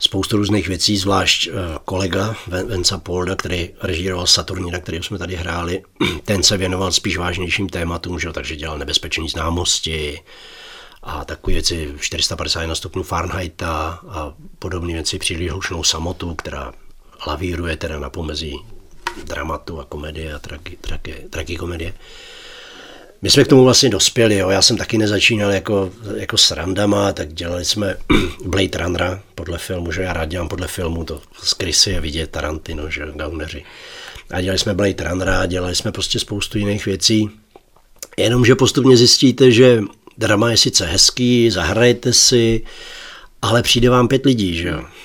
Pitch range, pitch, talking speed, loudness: 85-105 Hz, 95 Hz, 145 wpm, -17 LUFS